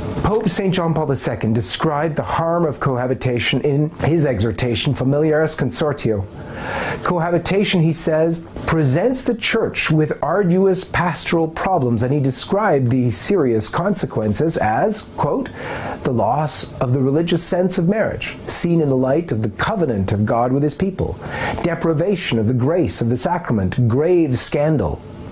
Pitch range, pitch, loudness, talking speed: 125-170 Hz, 150 Hz, -18 LUFS, 145 wpm